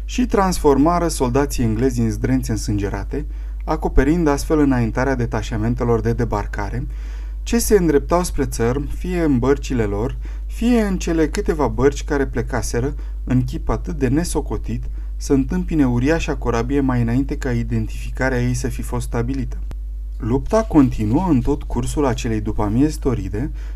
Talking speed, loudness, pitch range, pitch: 140 wpm, -20 LUFS, 115-145 Hz, 130 Hz